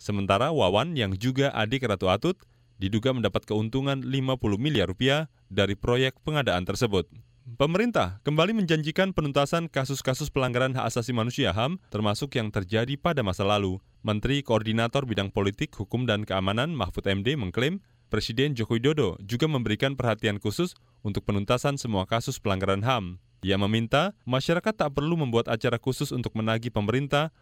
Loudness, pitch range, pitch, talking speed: -27 LUFS, 105-140 Hz, 120 Hz, 145 wpm